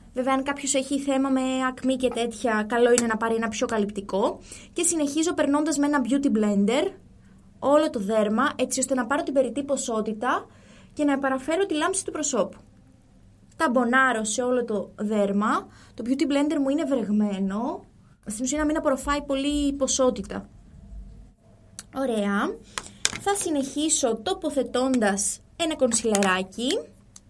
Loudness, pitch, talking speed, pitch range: -24 LUFS, 260 Hz, 140 wpm, 230-290 Hz